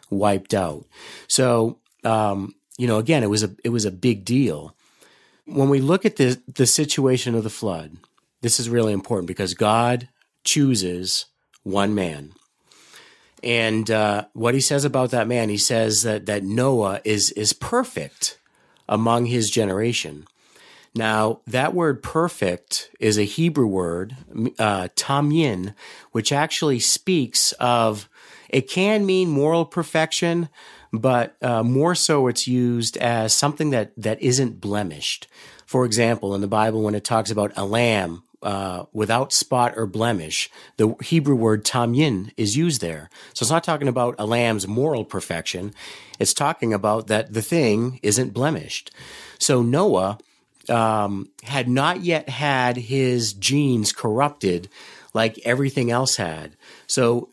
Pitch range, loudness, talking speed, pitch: 105-135 Hz, -21 LUFS, 145 wpm, 120 Hz